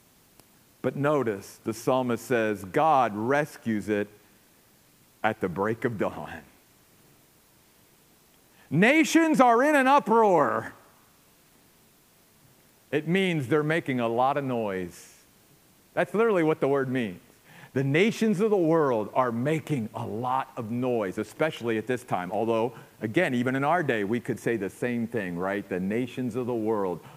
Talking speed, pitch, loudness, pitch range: 145 wpm, 130 Hz, -26 LUFS, 115-160 Hz